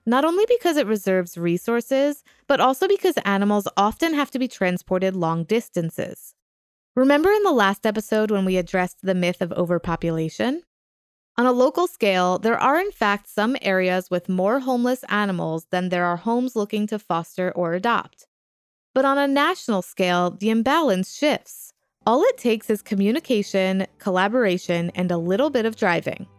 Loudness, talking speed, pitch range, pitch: -22 LUFS, 165 wpm, 180-260 Hz, 205 Hz